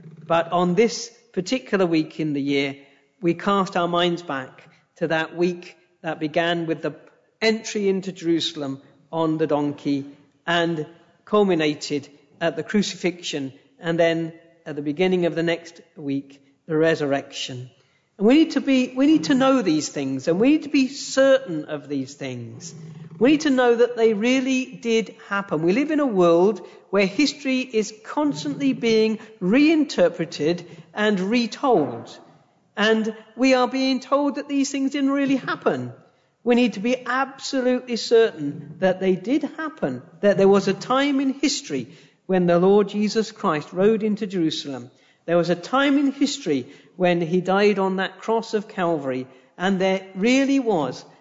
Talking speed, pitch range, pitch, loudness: 160 wpm, 160-240 Hz, 185 Hz, -22 LUFS